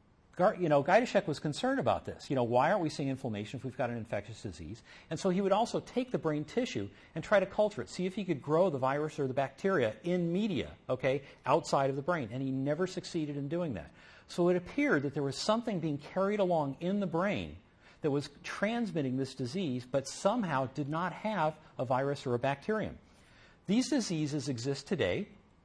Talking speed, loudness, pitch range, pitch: 210 wpm, -33 LUFS, 135-185 Hz, 150 Hz